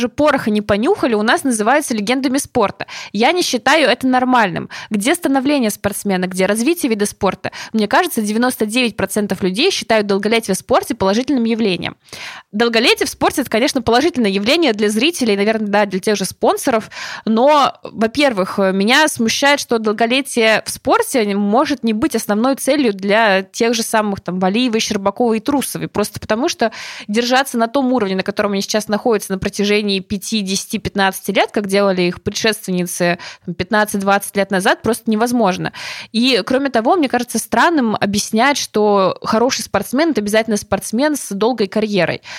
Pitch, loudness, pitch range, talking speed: 225 Hz, -16 LUFS, 205-255 Hz, 155 wpm